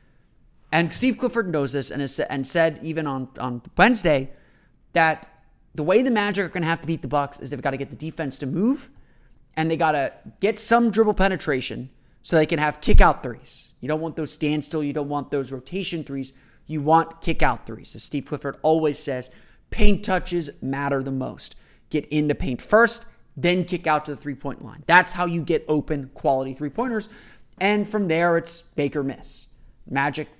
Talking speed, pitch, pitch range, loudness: 205 wpm, 155 Hz, 140-175 Hz, -23 LUFS